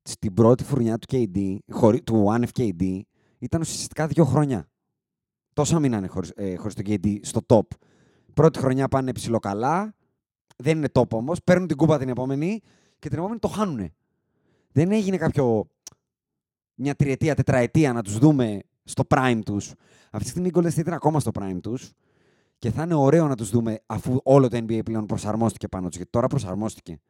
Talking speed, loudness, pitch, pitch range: 175 wpm, -23 LUFS, 125 Hz, 110-150 Hz